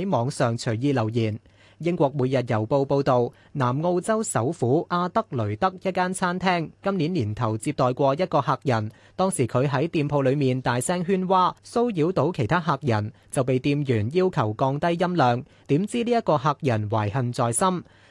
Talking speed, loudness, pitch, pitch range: 255 characters per minute, -24 LUFS, 140 Hz, 120-175 Hz